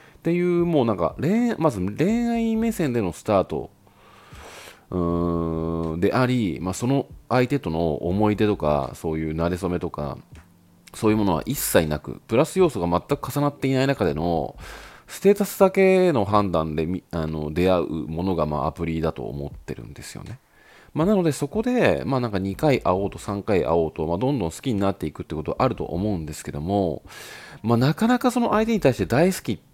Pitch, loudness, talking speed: 100 Hz, -23 LUFS, 365 characters per minute